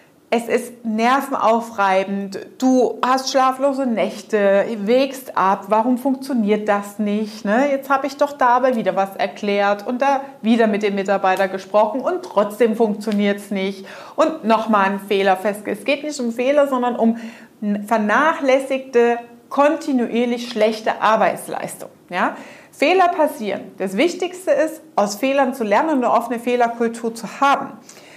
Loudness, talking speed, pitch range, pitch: -19 LUFS, 145 wpm, 205-270 Hz, 235 Hz